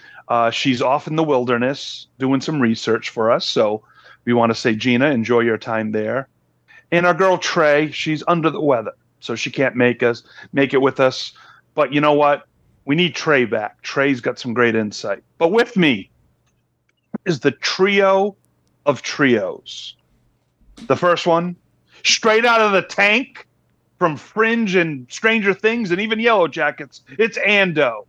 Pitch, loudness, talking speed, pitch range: 145 Hz, -18 LUFS, 165 wpm, 120-185 Hz